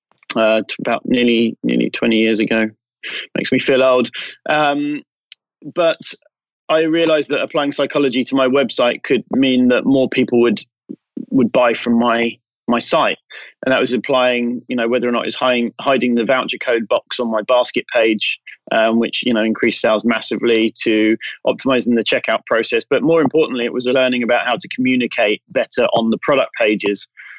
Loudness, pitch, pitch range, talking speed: -16 LUFS, 120 Hz, 115-130 Hz, 175 wpm